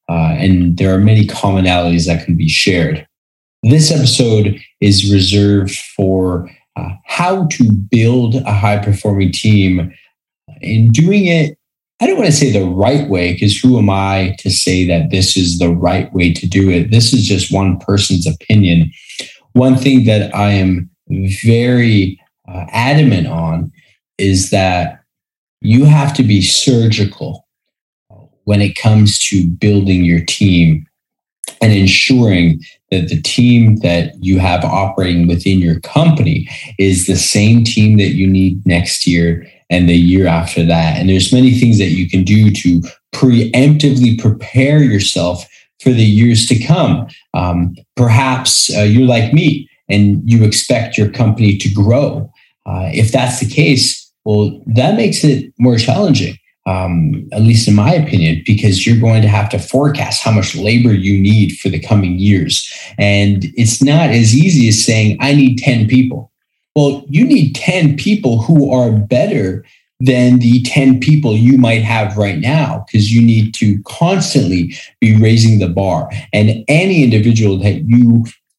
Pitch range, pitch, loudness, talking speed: 95-125 Hz, 105 Hz, -11 LUFS, 160 wpm